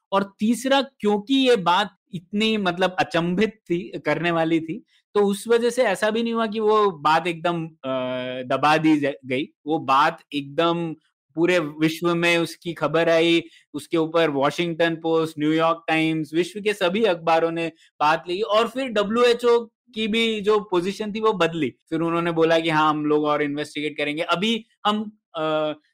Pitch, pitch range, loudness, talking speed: 170 Hz, 155-210 Hz, -22 LUFS, 170 wpm